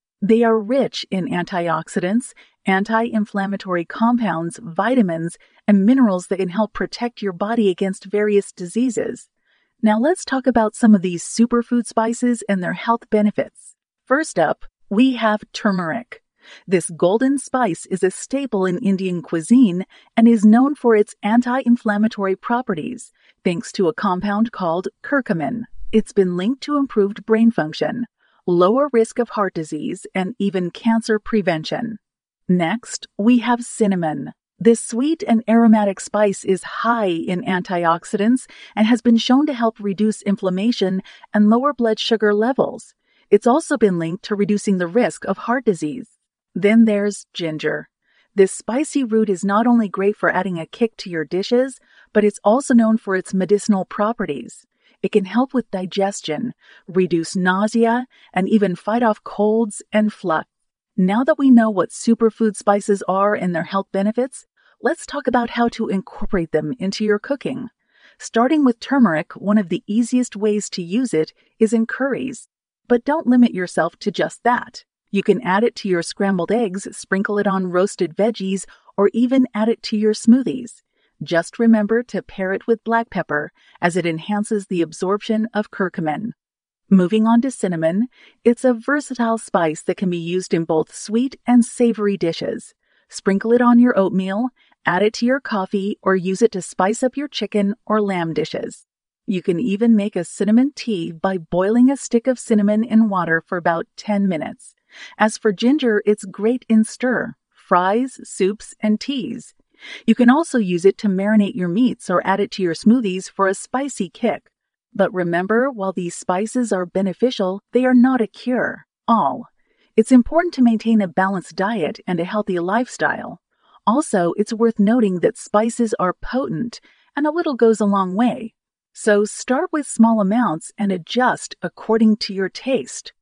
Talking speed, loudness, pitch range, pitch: 165 wpm, -19 LUFS, 190-240 Hz, 215 Hz